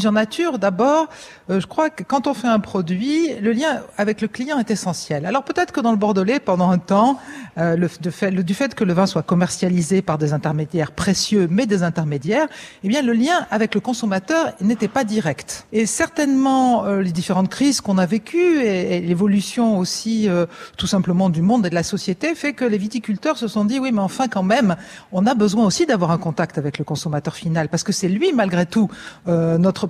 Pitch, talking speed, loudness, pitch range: 205 Hz, 220 wpm, -19 LUFS, 180-245 Hz